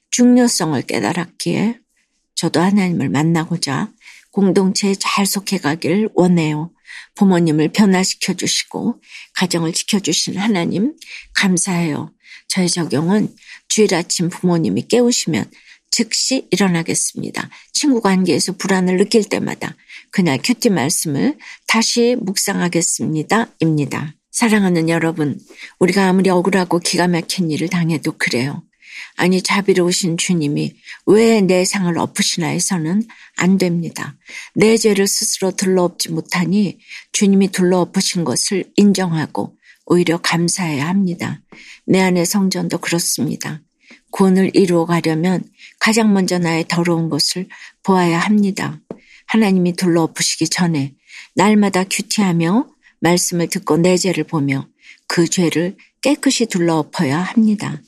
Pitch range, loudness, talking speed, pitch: 165-200 Hz, -16 LUFS, 295 characters per minute, 180 Hz